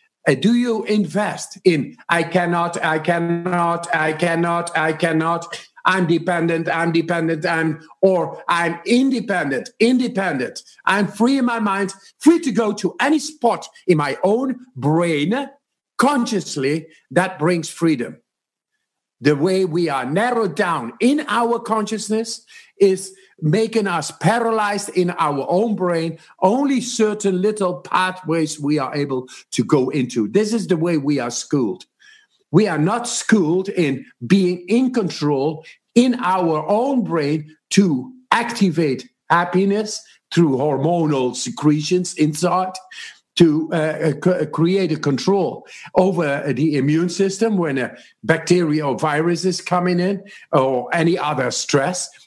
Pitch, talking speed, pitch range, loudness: 180 Hz, 130 wpm, 160-215 Hz, -19 LUFS